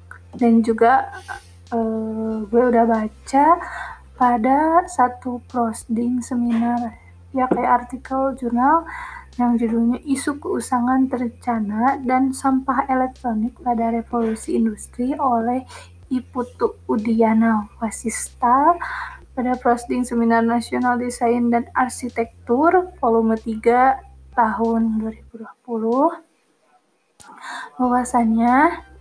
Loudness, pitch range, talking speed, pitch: -20 LUFS, 230-260 Hz, 85 wpm, 245 Hz